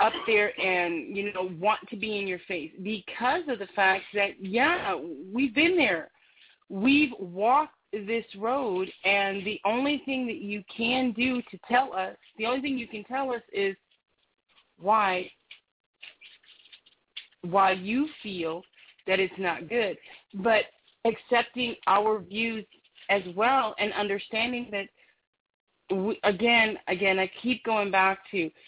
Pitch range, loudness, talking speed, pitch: 195-240 Hz, -27 LUFS, 140 wpm, 210 Hz